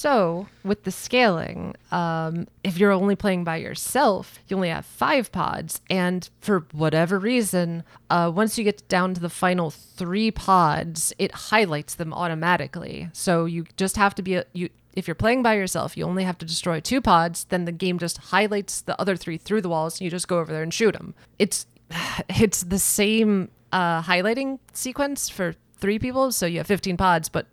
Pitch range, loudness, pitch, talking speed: 170-200 Hz, -23 LUFS, 180 Hz, 195 wpm